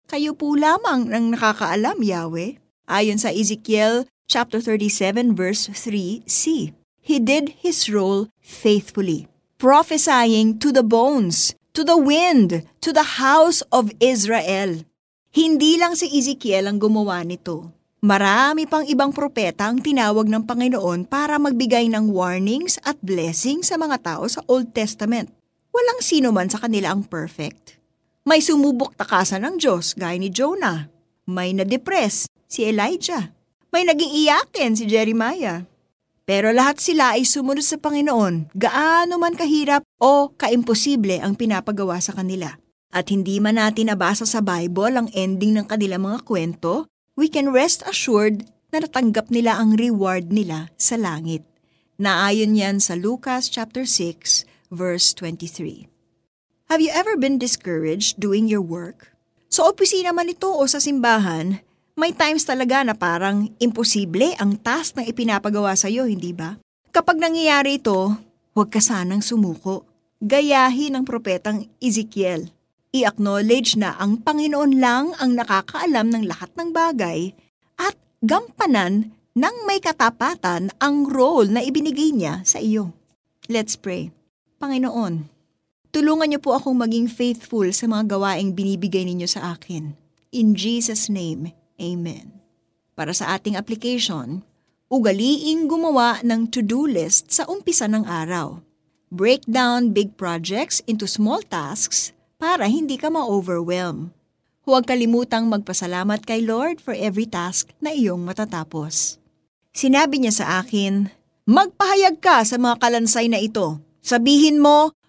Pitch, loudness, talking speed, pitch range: 225 Hz, -19 LUFS, 135 wpm, 195-275 Hz